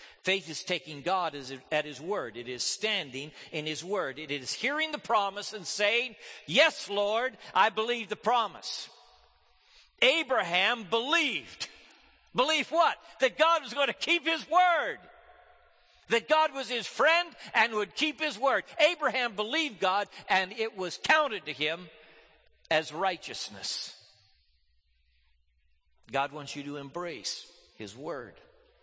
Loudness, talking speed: -29 LUFS, 135 wpm